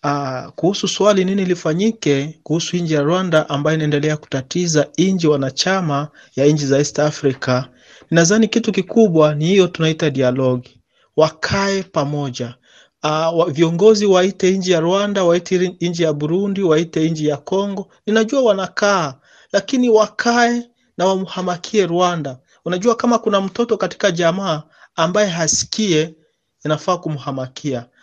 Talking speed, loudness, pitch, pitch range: 125 wpm, -17 LUFS, 170 Hz, 150-195 Hz